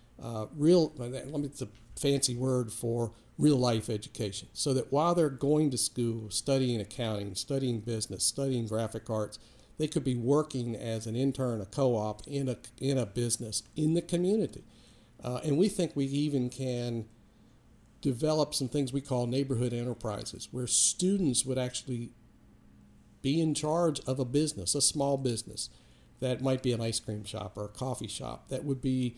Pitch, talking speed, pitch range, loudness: 125 Hz, 175 wpm, 115-140 Hz, -31 LUFS